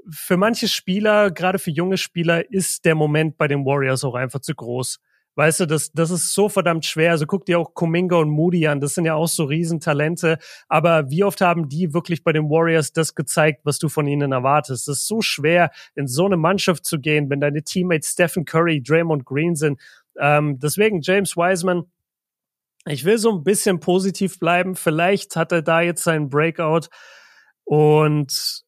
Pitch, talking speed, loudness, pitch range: 165 Hz, 190 wpm, -19 LUFS, 150-180 Hz